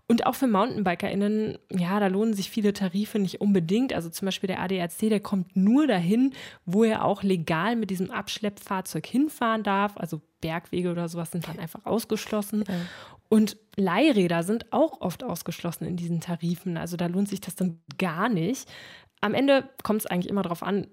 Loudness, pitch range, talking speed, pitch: -26 LUFS, 175-215 Hz, 180 wpm, 195 Hz